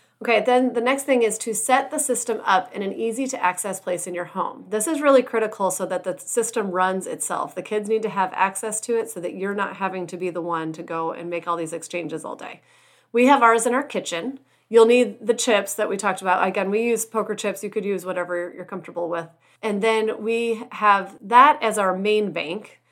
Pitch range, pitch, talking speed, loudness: 185-230 Hz, 210 Hz, 240 wpm, -22 LUFS